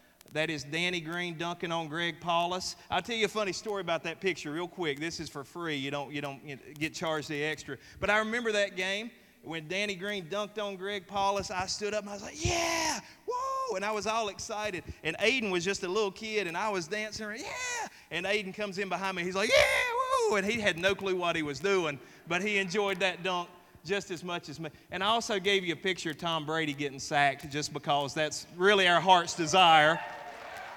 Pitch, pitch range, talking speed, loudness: 185 Hz, 165-205 Hz, 230 wpm, -30 LUFS